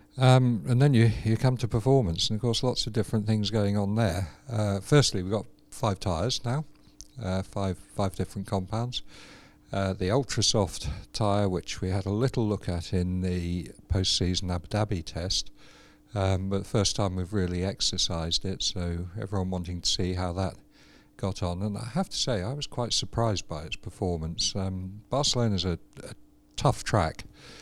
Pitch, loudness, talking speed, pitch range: 100 Hz, -28 LUFS, 185 wpm, 95-115 Hz